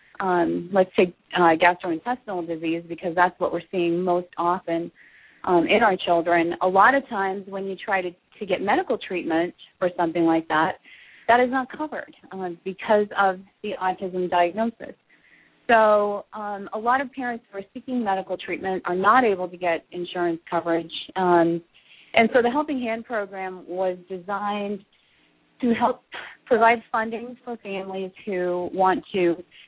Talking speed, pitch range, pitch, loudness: 160 wpm, 175-225 Hz, 190 Hz, -23 LUFS